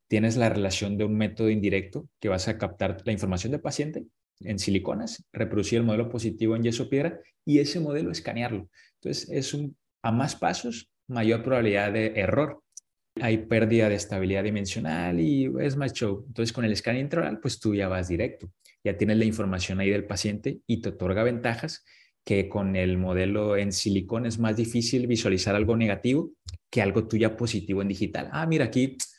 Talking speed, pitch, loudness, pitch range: 180 wpm, 110 Hz, -27 LUFS, 100-120 Hz